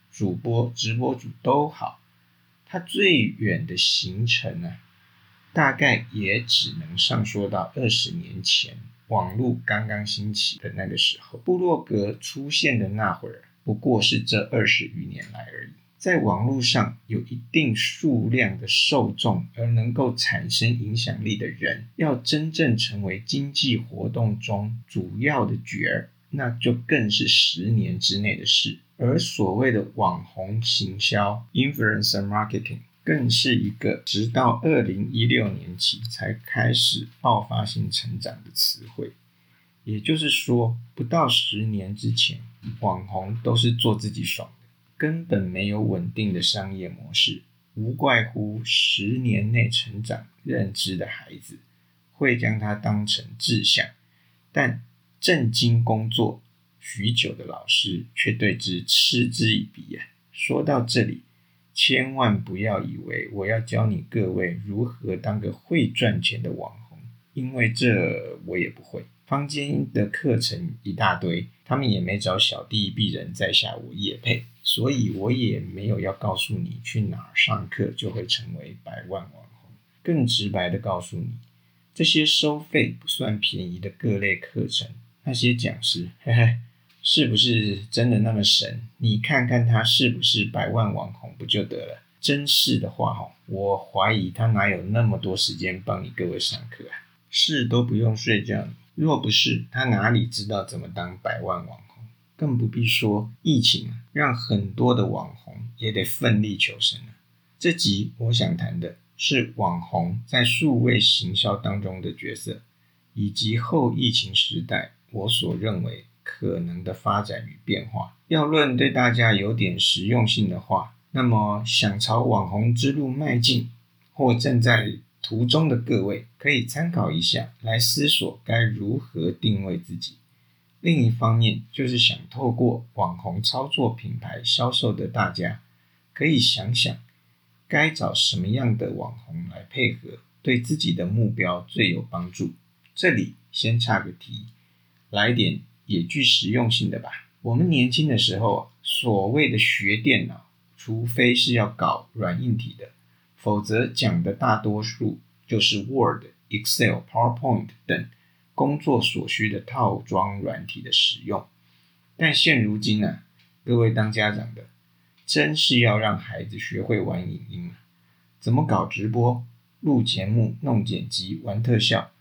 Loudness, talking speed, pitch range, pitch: -23 LUFS, 230 characters per minute, 95-120 Hz, 110 Hz